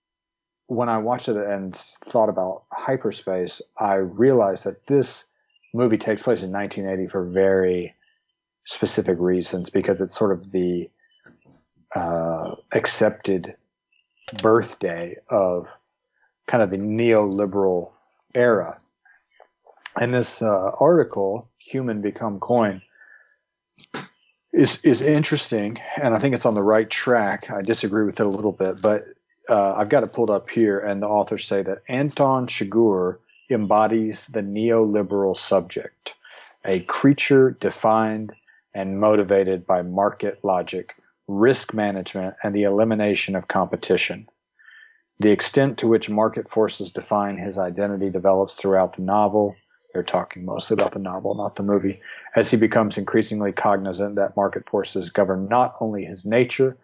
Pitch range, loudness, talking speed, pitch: 95-115 Hz, -22 LUFS, 135 wpm, 105 Hz